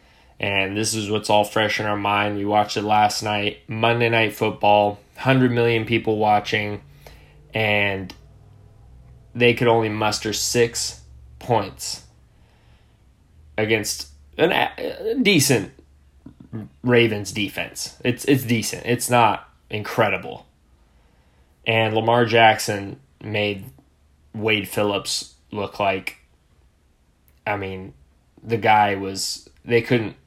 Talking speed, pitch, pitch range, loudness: 105 wpm, 105 Hz, 75-110 Hz, -21 LUFS